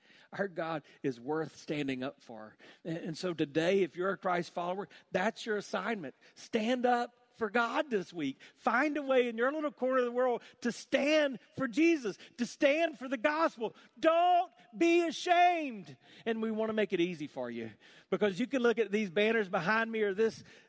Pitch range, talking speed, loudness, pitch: 180-265 Hz, 190 wpm, -32 LUFS, 225 Hz